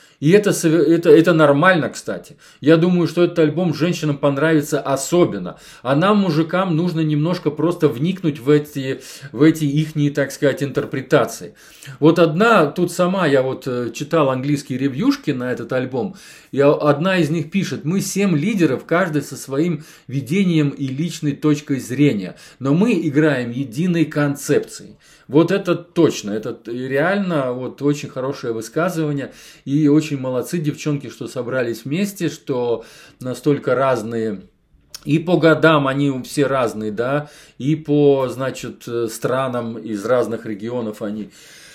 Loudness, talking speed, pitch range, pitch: -18 LUFS, 140 wpm, 135-165 Hz, 150 Hz